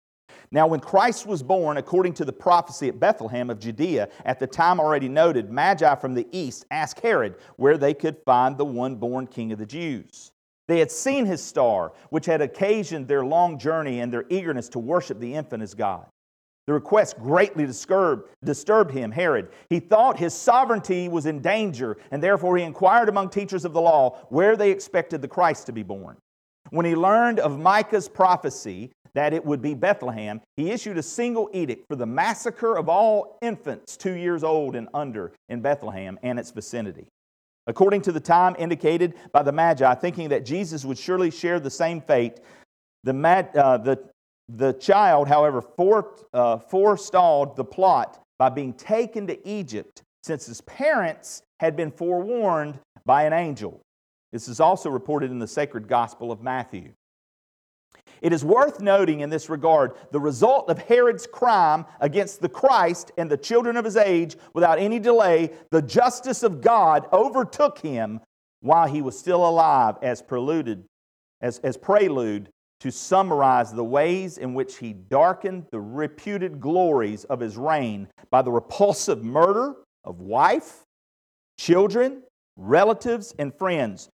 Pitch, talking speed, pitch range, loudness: 160 Hz, 165 wpm, 130-190 Hz, -22 LUFS